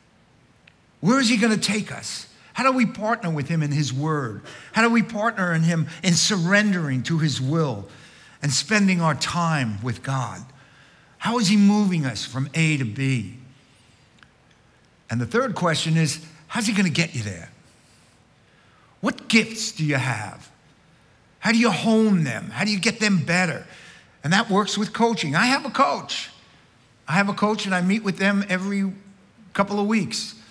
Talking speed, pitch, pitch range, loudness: 180 wpm, 175 Hz, 140-210 Hz, -22 LUFS